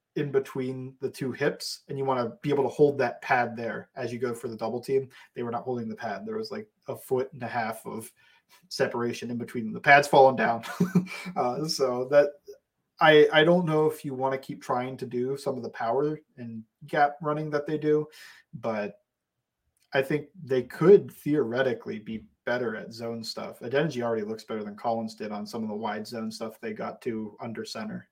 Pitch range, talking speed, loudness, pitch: 115-150 Hz, 215 wpm, -27 LUFS, 135 Hz